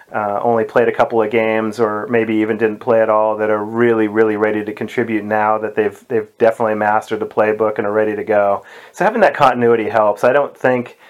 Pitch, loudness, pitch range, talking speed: 110 Hz, -16 LUFS, 105-115 Hz, 225 wpm